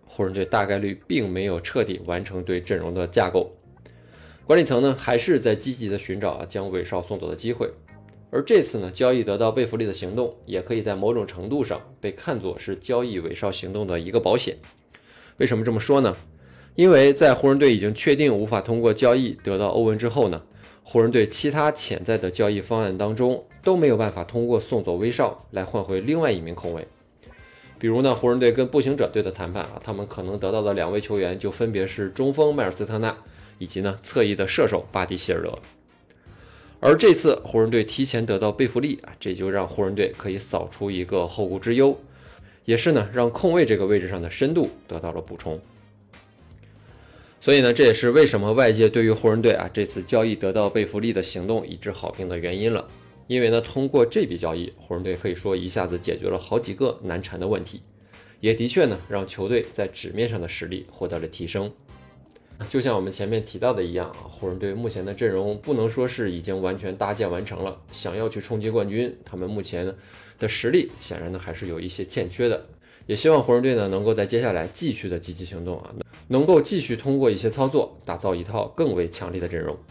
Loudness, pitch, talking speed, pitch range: -23 LUFS, 105 Hz, 320 characters per minute, 95-120 Hz